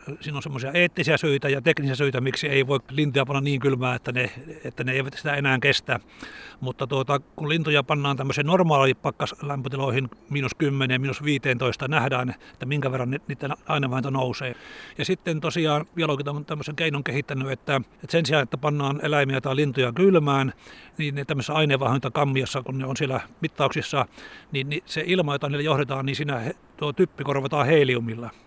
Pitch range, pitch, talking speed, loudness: 135-150 Hz, 140 Hz, 170 wpm, -24 LUFS